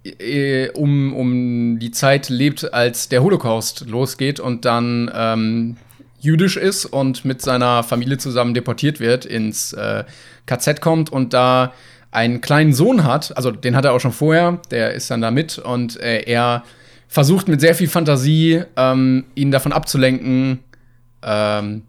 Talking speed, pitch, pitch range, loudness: 155 wpm, 130 Hz, 120-145 Hz, -17 LUFS